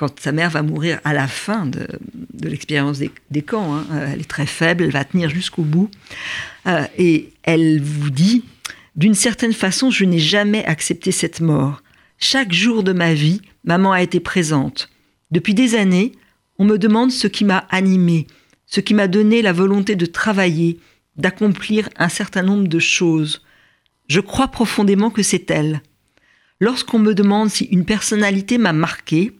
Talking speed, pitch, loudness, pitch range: 175 wpm, 185 Hz, -17 LUFS, 155-210 Hz